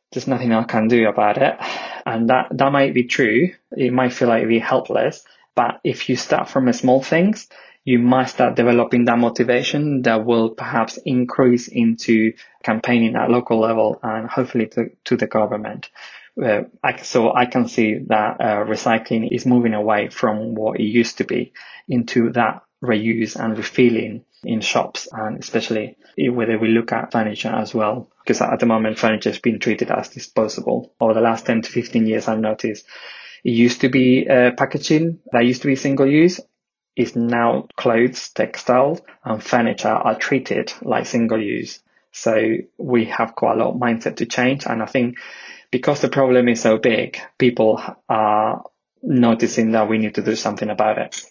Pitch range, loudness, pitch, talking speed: 110-125 Hz, -19 LUFS, 120 Hz, 180 wpm